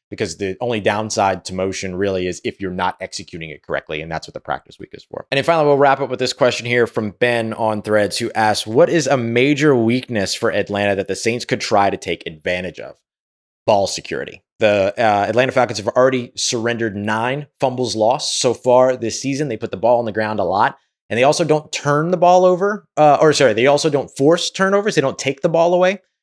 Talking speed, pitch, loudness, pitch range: 230 wpm, 120 Hz, -17 LUFS, 105-145 Hz